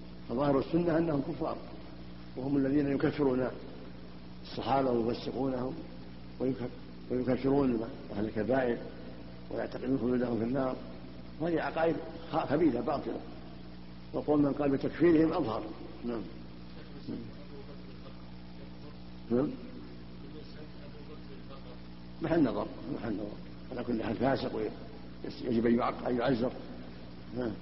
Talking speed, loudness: 85 wpm, -32 LUFS